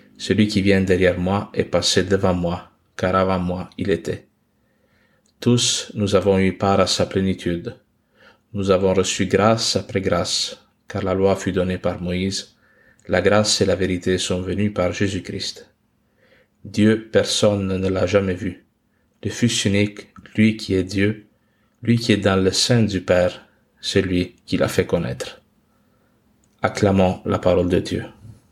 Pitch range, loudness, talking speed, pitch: 95-105 Hz, -20 LUFS, 160 wpm, 100 Hz